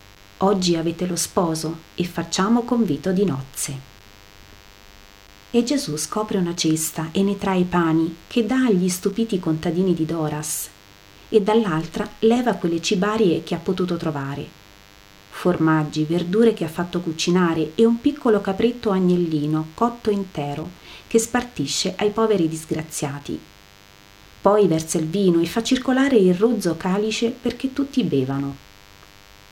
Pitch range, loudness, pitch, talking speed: 145-210 Hz, -21 LUFS, 170 Hz, 135 wpm